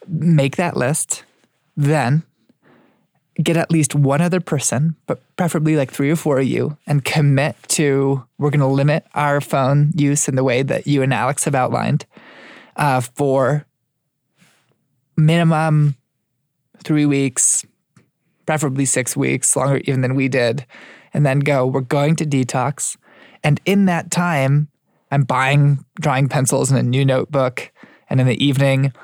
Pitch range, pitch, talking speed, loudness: 135-155 Hz, 145 Hz, 150 wpm, -17 LUFS